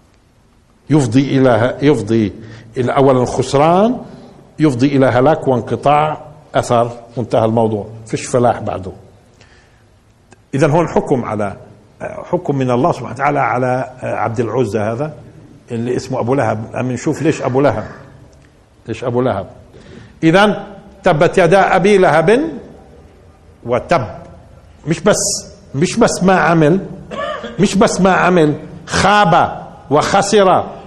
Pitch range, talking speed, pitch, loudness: 115-170 Hz, 115 wpm, 135 Hz, -14 LUFS